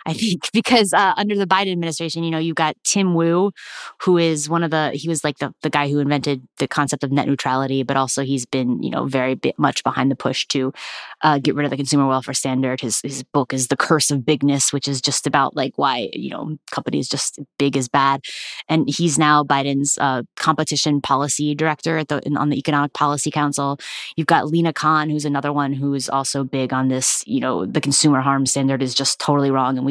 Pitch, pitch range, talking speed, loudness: 145 Hz, 135-155 Hz, 230 wpm, -19 LUFS